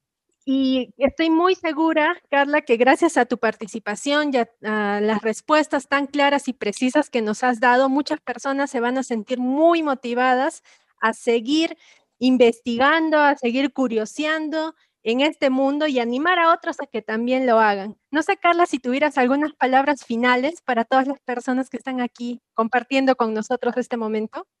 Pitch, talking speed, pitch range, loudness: 265 Hz, 170 wpm, 240-300 Hz, -20 LUFS